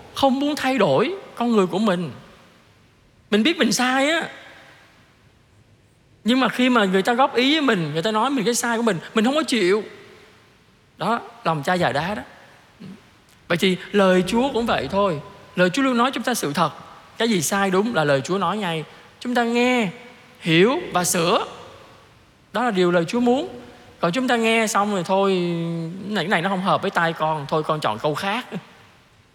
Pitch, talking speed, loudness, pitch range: 200 Hz, 200 wpm, -21 LUFS, 165-240 Hz